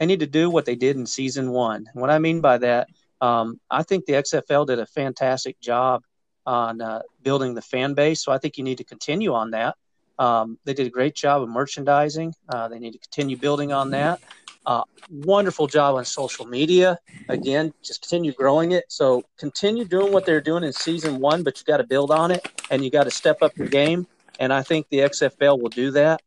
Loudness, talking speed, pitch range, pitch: -22 LUFS, 225 wpm, 130-155 Hz, 140 Hz